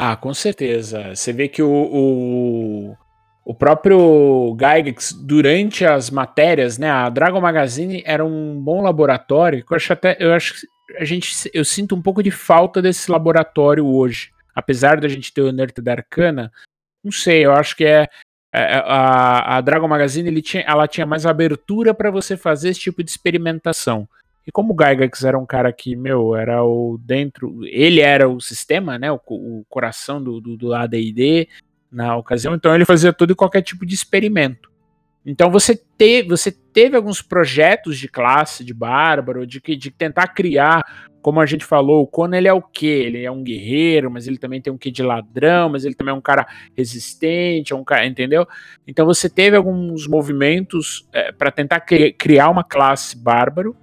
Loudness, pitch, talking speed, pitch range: -16 LUFS, 150 Hz, 180 wpm, 130-170 Hz